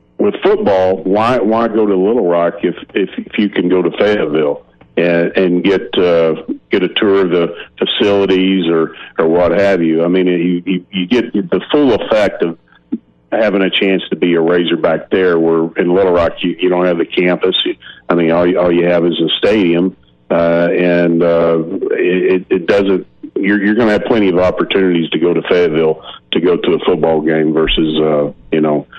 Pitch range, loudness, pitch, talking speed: 80-95 Hz, -13 LUFS, 85 Hz, 200 wpm